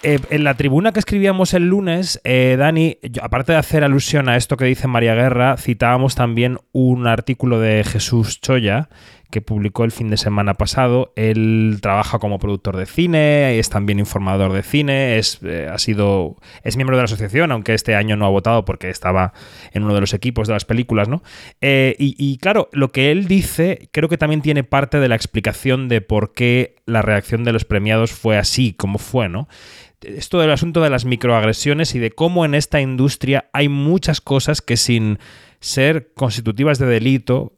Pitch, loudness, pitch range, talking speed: 125 Hz, -17 LUFS, 110-140 Hz, 195 wpm